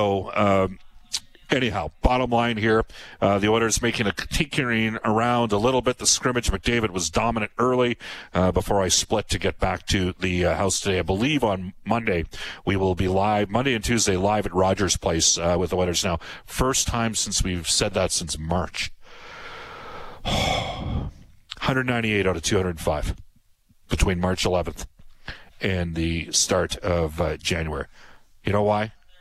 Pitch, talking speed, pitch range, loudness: 100 Hz, 160 wpm, 90-115 Hz, -23 LUFS